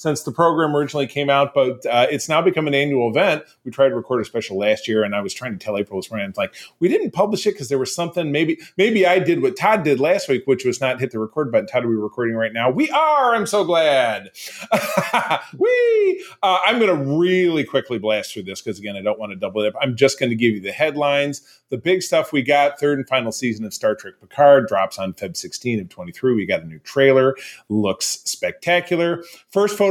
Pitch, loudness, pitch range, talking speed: 140 Hz, -19 LUFS, 115-180 Hz, 250 wpm